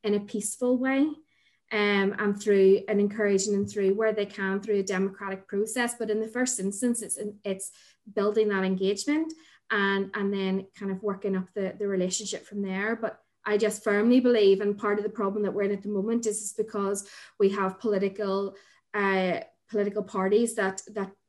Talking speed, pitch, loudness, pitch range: 190 wpm, 205 Hz, -27 LUFS, 195-215 Hz